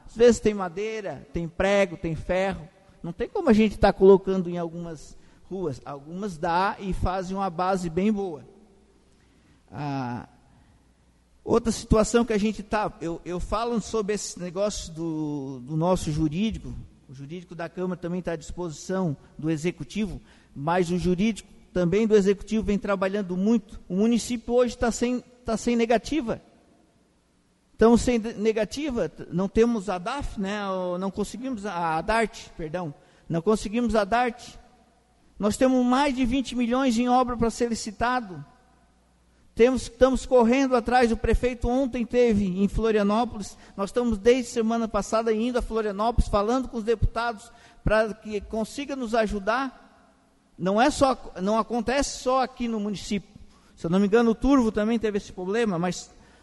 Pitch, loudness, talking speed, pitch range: 210 Hz, -25 LUFS, 155 wpm, 180-235 Hz